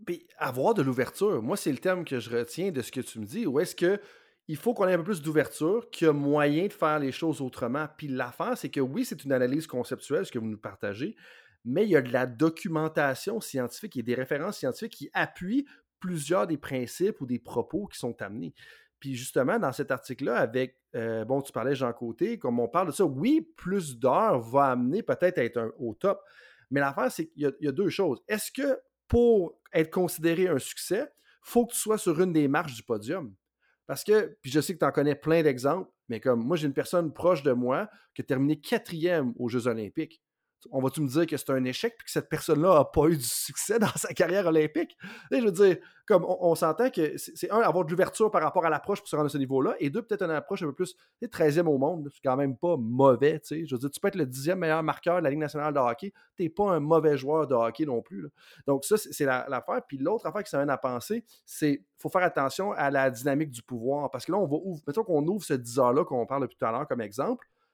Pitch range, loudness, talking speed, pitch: 135-185 Hz, -28 LUFS, 255 wpm, 155 Hz